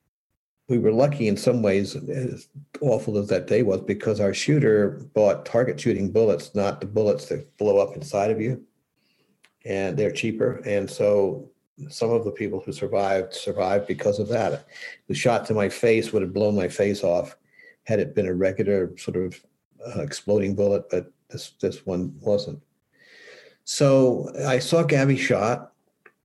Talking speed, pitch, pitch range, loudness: 170 wpm, 120 Hz, 100-145 Hz, -23 LUFS